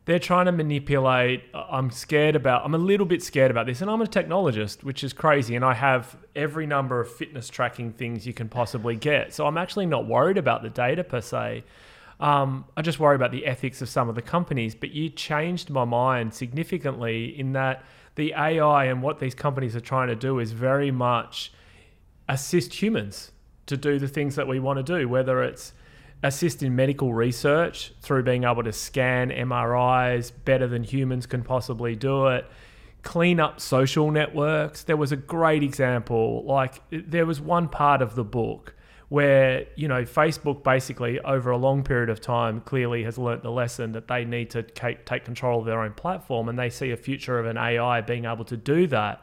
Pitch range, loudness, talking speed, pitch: 120-145 Hz, -25 LUFS, 200 wpm, 130 Hz